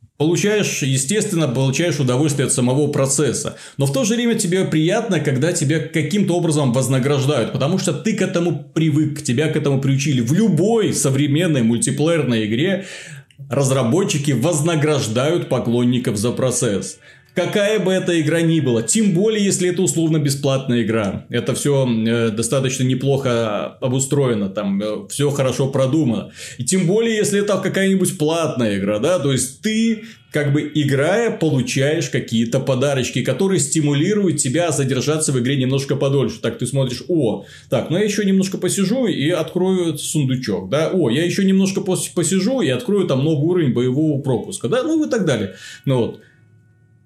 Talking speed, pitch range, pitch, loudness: 160 wpm, 130-175 Hz, 150 Hz, -18 LUFS